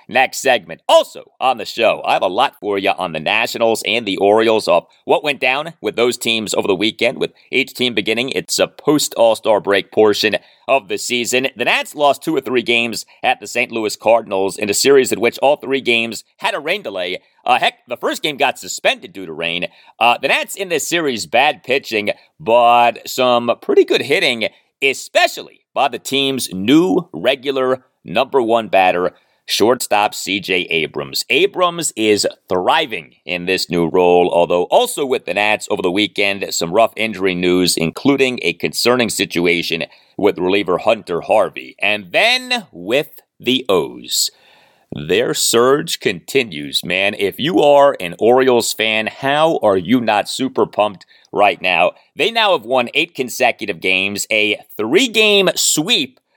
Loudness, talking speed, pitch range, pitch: -16 LUFS, 170 wpm, 105-150 Hz, 120 Hz